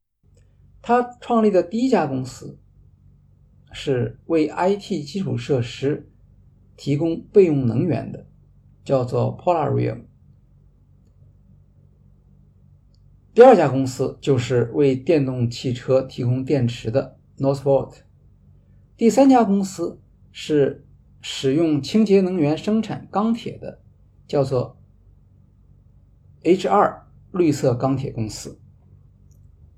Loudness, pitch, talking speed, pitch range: -20 LUFS, 135 Hz, 175 characters per minute, 115-165 Hz